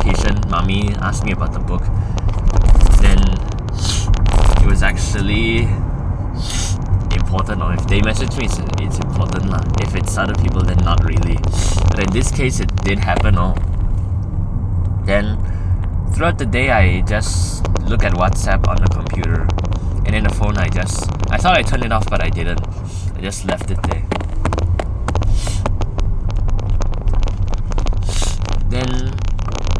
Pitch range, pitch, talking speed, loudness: 90-100 Hz, 95 Hz, 140 wpm, -18 LUFS